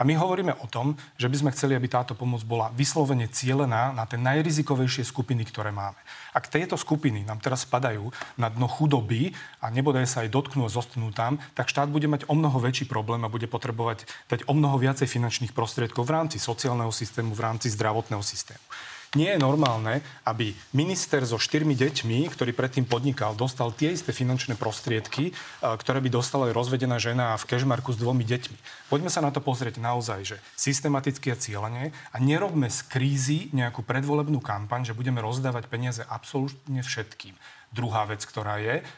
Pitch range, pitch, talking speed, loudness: 115-140 Hz, 125 Hz, 180 wpm, -27 LUFS